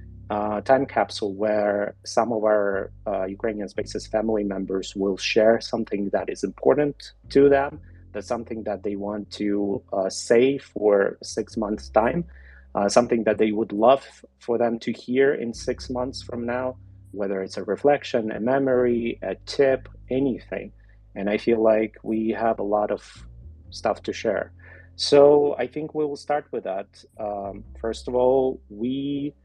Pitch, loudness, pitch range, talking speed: 110 Hz, -24 LUFS, 100-125 Hz, 165 wpm